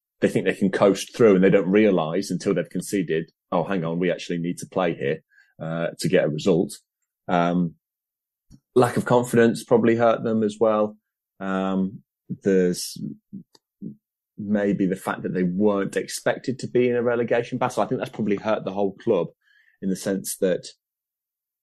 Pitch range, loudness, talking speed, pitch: 90-115 Hz, -23 LUFS, 175 wpm, 100 Hz